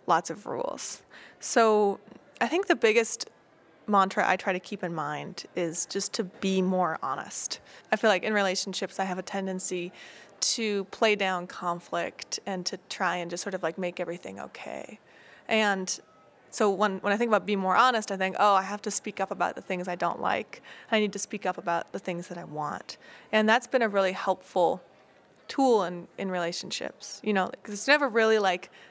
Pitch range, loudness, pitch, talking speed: 185-215 Hz, -28 LUFS, 195 Hz, 200 wpm